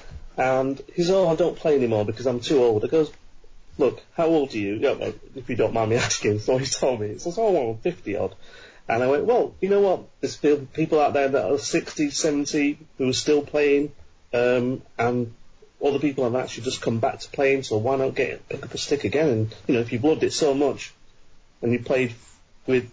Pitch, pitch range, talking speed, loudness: 135 Hz, 120-150 Hz, 230 wpm, -23 LUFS